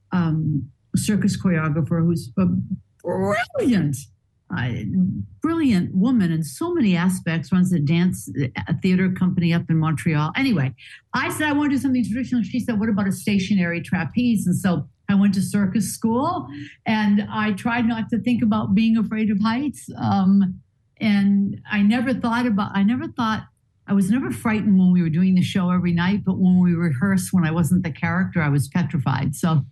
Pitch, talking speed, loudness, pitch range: 190 Hz, 180 wpm, -21 LUFS, 170-220 Hz